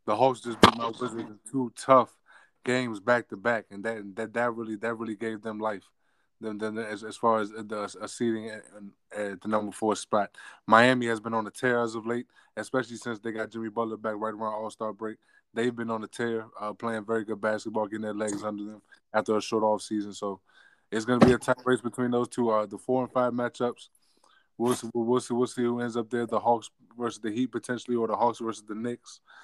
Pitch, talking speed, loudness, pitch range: 115 Hz, 240 wpm, -29 LUFS, 110-120 Hz